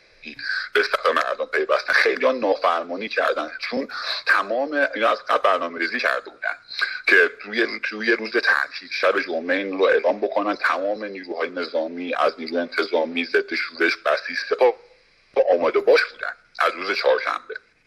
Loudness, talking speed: -22 LUFS, 140 wpm